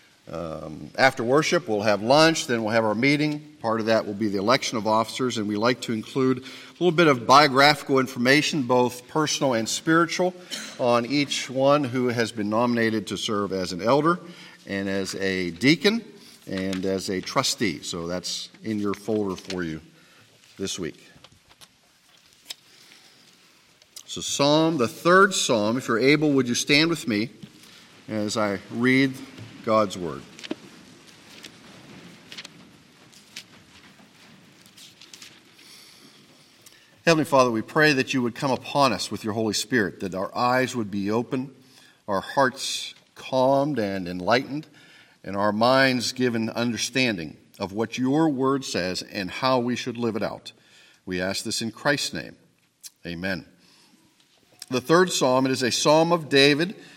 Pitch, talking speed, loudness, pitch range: 125 Hz, 145 wpm, -23 LUFS, 105-140 Hz